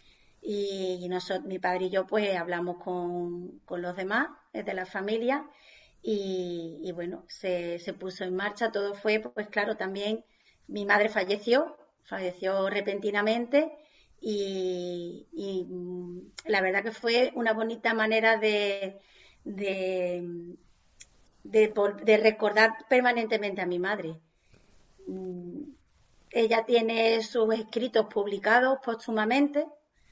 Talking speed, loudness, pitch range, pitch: 115 wpm, -28 LUFS, 185-225 Hz, 205 Hz